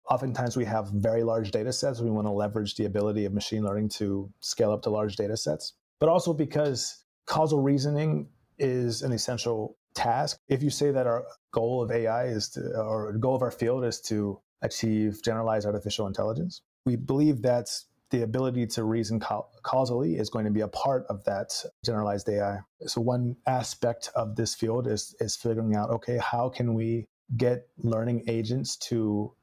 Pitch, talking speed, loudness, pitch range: 115 Hz, 185 wpm, -29 LUFS, 105-125 Hz